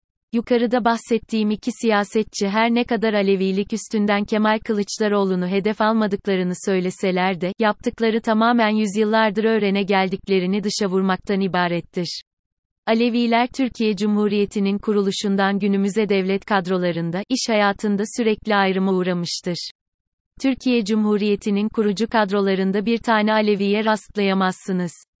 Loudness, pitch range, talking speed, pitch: -20 LUFS, 195-220 Hz, 100 wpm, 205 Hz